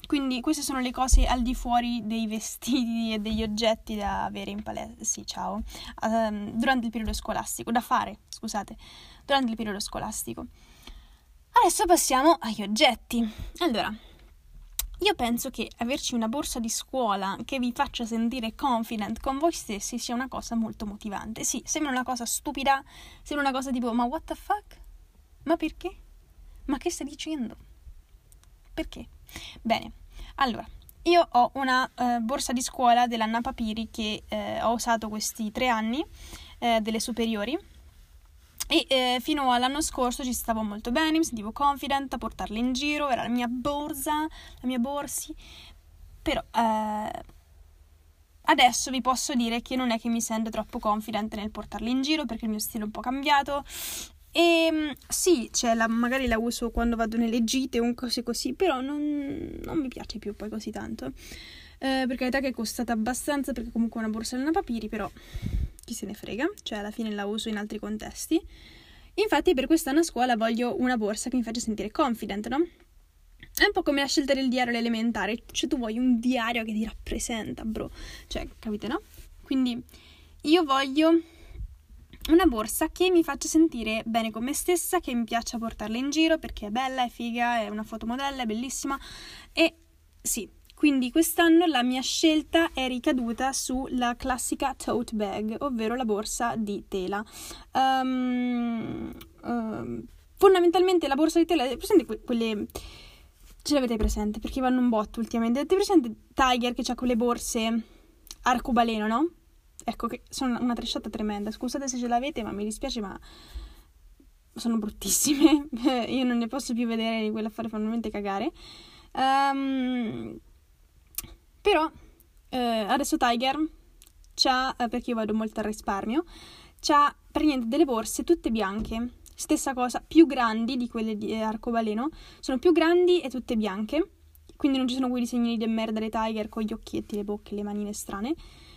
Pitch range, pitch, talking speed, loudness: 220-280 Hz, 245 Hz, 165 wpm, -27 LUFS